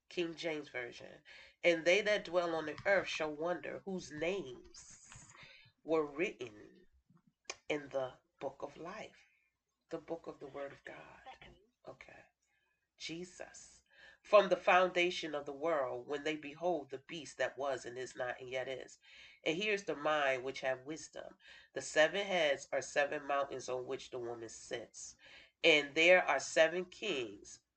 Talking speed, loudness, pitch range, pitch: 155 wpm, -35 LUFS, 140-180 Hz, 160 Hz